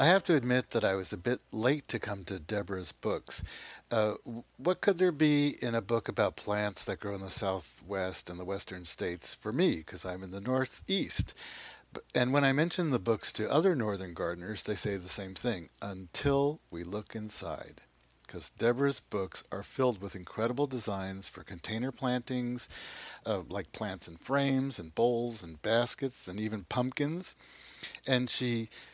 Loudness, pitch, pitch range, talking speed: -33 LUFS, 110 Hz, 95-130 Hz, 175 wpm